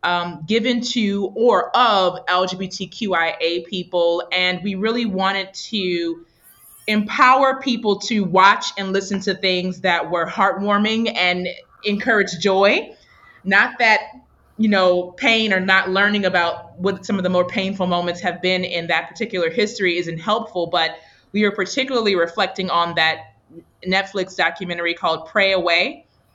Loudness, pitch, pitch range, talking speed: -19 LUFS, 190 Hz, 175-205 Hz, 140 wpm